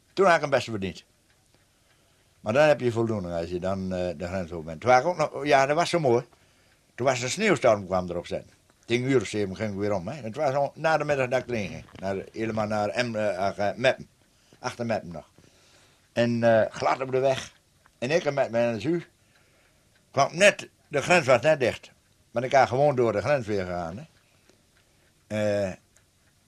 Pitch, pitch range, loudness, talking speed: 110 Hz, 95-130 Hz, -25 LUFS, 190 wpm